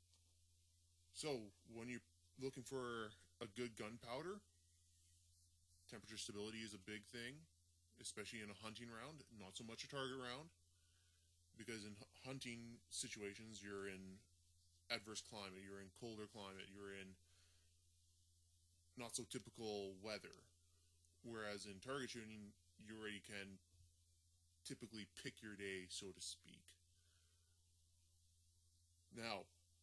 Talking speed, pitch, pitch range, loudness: 115 wpm, 95 Hz, 85-115 Hz, -53 LUFS